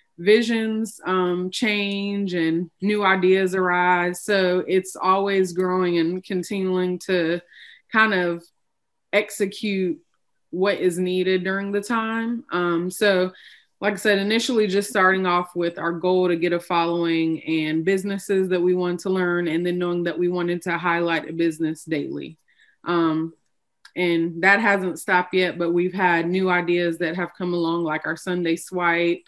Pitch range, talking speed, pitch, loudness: 170-195 Hz, 155 wpm, 180 Hz, -22 LUFS